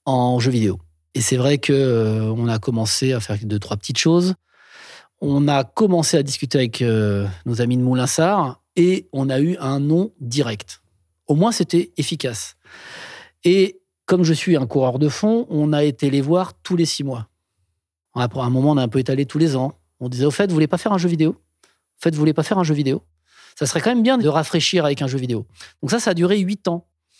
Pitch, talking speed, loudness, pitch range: 140 Hz, 230 wpm, -19 LUFS, 120-170 Hz